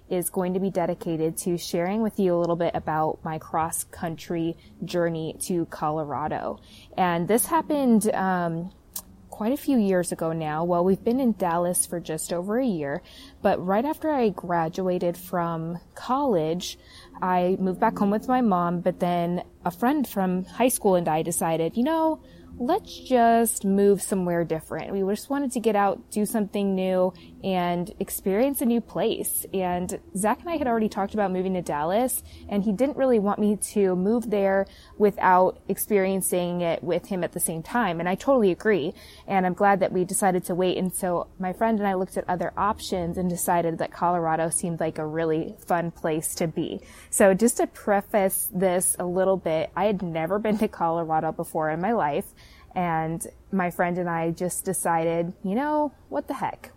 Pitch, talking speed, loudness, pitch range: 185 Hz, 185 wpm, -25 LUFS, 170-210 Hz